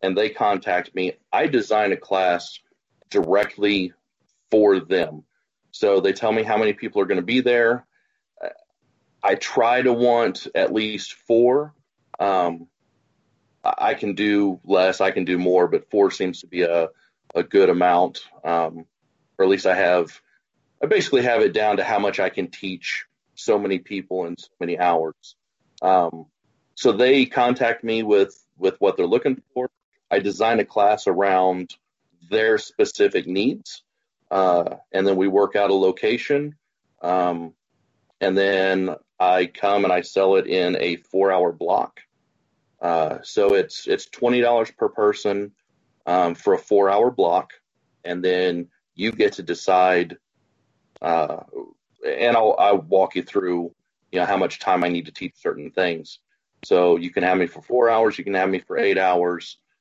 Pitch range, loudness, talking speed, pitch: 90-125 Hz, -21 LUFS, 165 wpm, 100 Hz